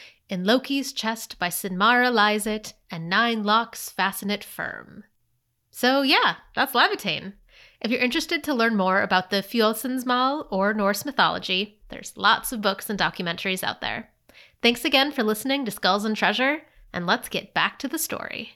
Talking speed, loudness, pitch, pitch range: 170 wpm, -23 LUFS, 220 Hz, 195-255 Hz